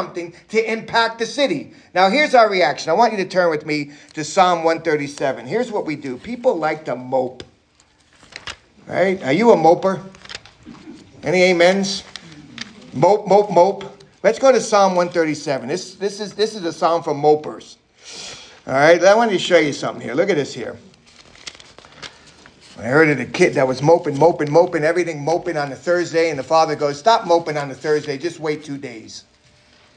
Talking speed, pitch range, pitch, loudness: 185 wpm, 150-195 Hz, 170 Hz, -17 LUFS